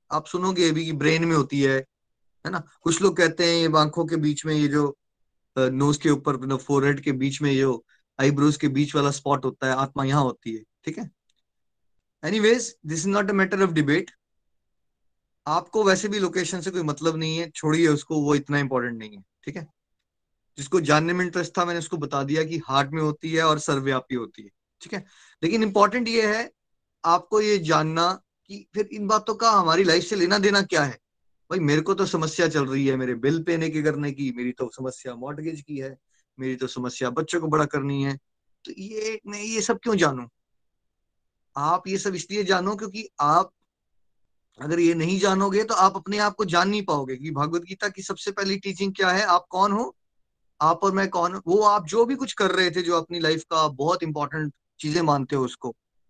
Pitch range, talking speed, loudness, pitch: 140-190 Hz, 205 wpm, -23 LUFS, 160 Hz